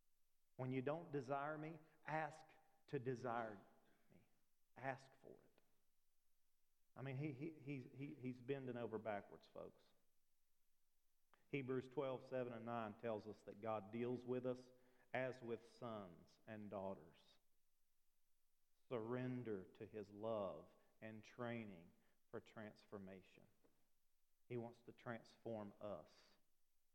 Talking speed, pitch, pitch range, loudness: 120 wpm, 125 Hz, 110-135 Hz, -51 LUFS